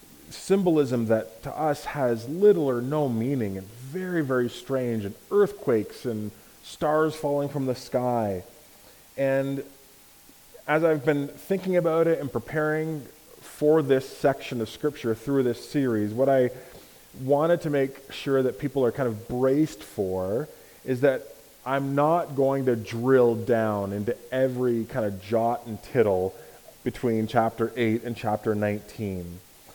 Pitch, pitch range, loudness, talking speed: 130 Hz, 115-145 Hz, -26 LUFS, 145 wpm